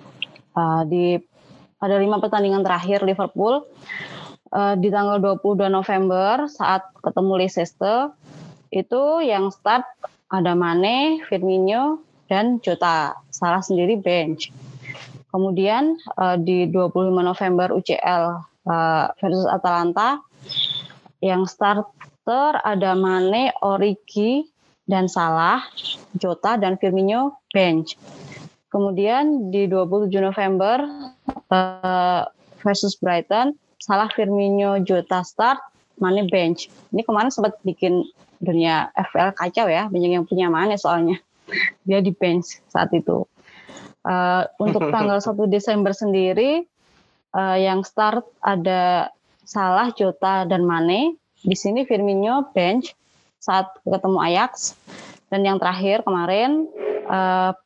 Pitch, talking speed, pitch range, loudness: 190 Hz, 105 wpm, 180-210 Hz, -20 LUFS